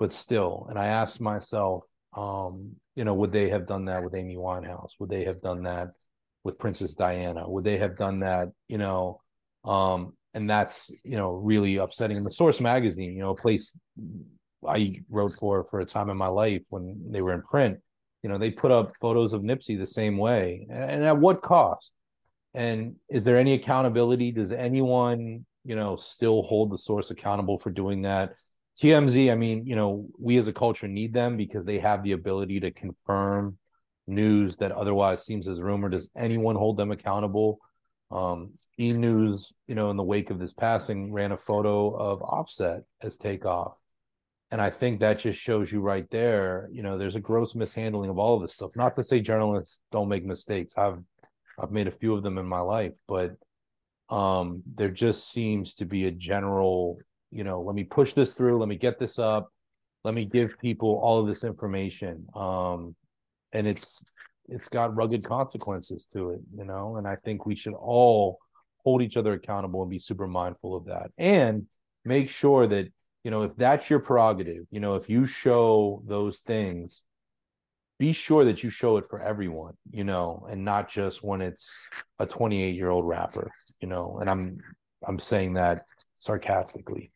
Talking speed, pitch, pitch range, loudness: 190 wpm, 105 Hz, 95-115 Hz, -27 LUFS